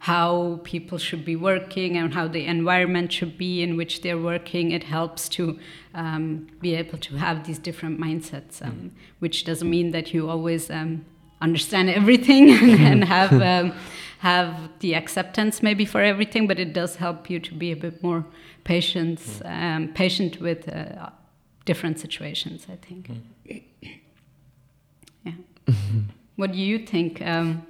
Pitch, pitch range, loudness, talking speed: 170 Hz, 160-180 Hz, -22 LUFS, 150 wpm